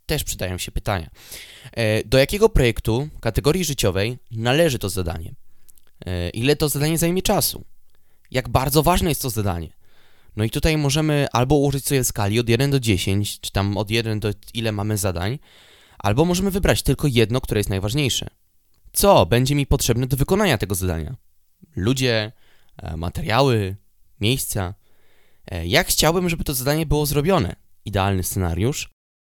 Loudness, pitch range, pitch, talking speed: -21 LUFS, 100-140 Hz, 115 Hz, 145 wpm